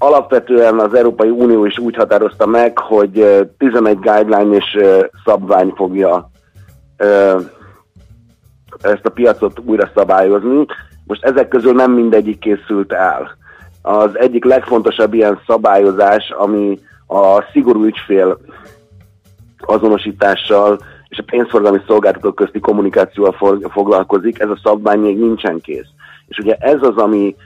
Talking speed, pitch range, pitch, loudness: 120 wpm, 100-115 Hz, 105 Hz, -12 LUFS